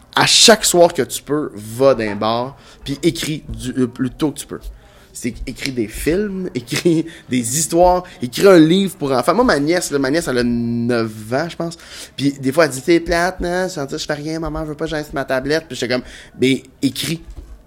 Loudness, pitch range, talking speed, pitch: -17 LUFS, 125-170 Hz, 215 wpm, 145 Hz